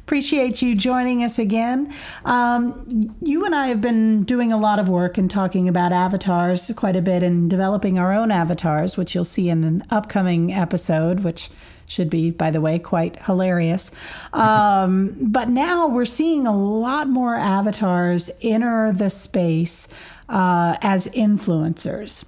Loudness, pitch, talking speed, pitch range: -20 LUFS, 200 Hz, 155 wpm, 180-235 Hz